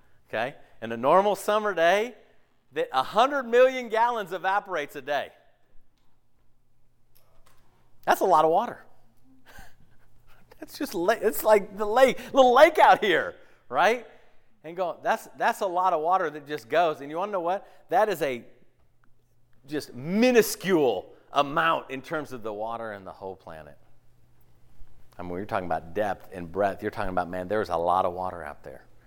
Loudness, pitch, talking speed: -25 LUFS, 130 Hz, 170 wpm